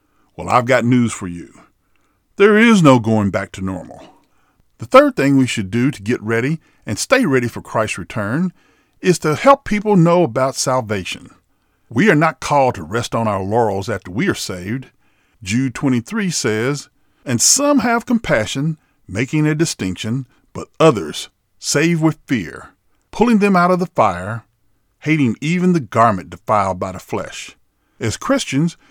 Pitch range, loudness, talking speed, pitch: 110-165 Hz, -16 LUFS, 165 wpm, 130 Hz